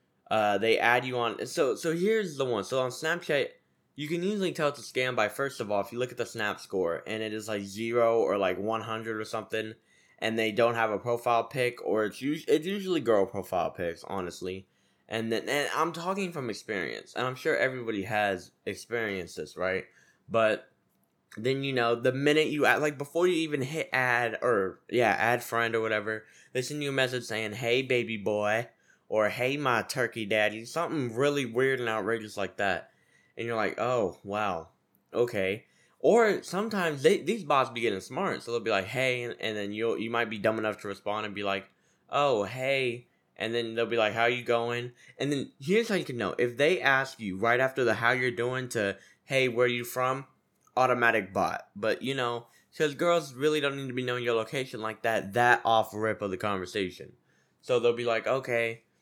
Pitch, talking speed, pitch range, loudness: 120 Hz, 210 wpm, 110-130 Hz, -29 LUFS